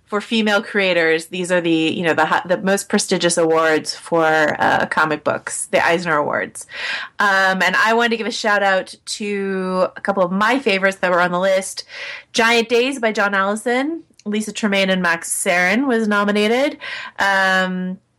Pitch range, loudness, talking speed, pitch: 180-225 Hz, -17 LUFS, 175 wpm, 195 Hz